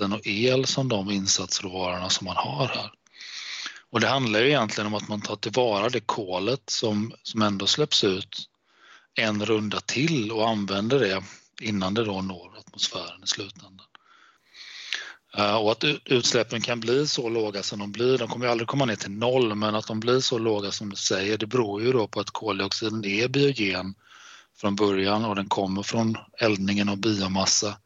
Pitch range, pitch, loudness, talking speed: 100-115 Hz, 105 Hz, -25 LUFS, 180 wpm